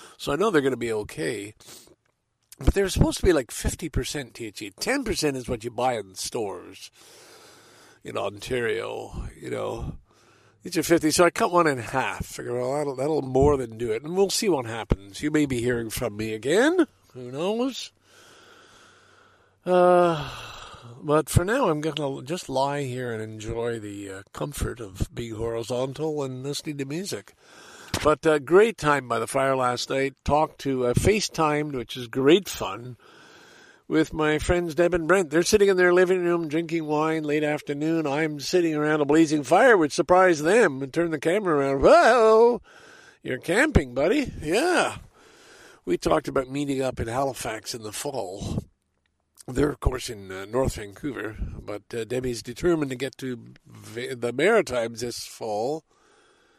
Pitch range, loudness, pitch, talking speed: 125-180 Hz, -24 LUFS, 150 Hz, 170 wpm